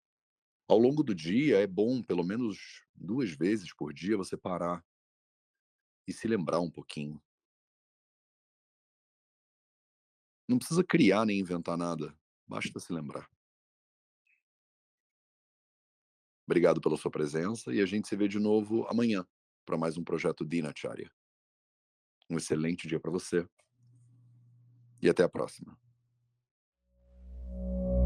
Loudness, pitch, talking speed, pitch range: -31 LUFS, 90 Hz, 115 wpm, 75-120 Hz